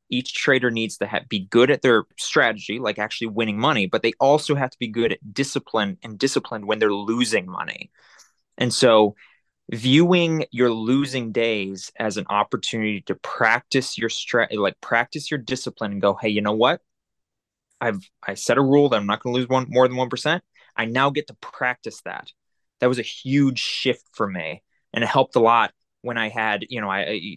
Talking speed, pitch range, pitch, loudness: 205 wpm, 110-135 Hz, 125 Hz, -21 LUFS